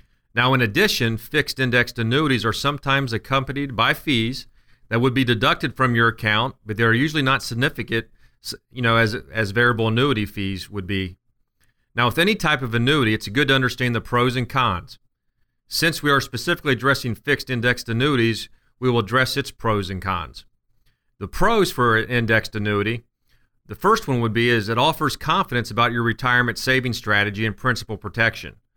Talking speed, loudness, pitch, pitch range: 175 wpm, -20 LUFS, 120 Hz, 115-135 Hz